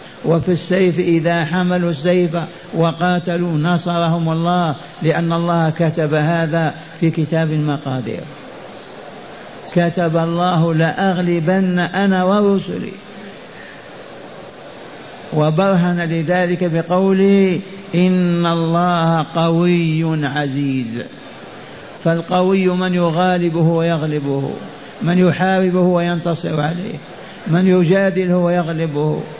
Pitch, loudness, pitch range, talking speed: 170 Hz, -16 LUFS, 165-180 Hz, 80 wpm